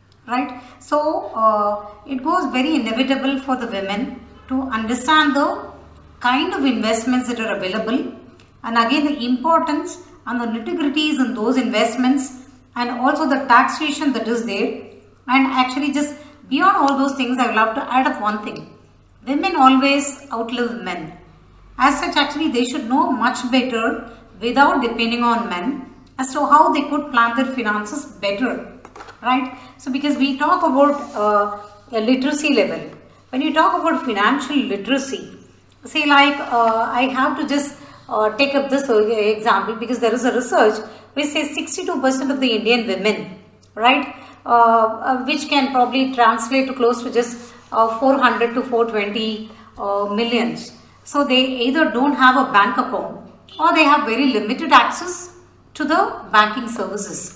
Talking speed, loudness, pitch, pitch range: 160 wpm, -18 LUFS, 255 Hz, 230-285 Hz